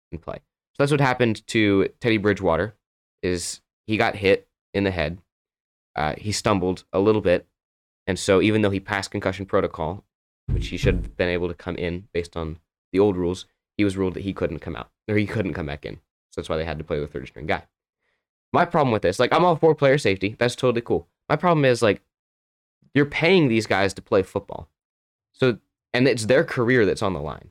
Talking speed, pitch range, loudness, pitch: 225 wpm, 85-115 Hz, -23 LUFS, 100 Hz